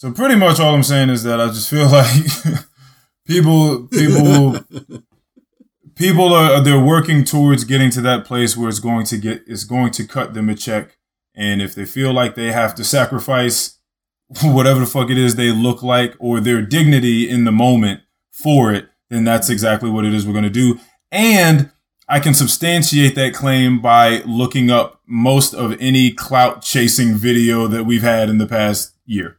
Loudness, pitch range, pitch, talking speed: -14 LUFS, 115-140 Hz, 125 Hz, 190 wpm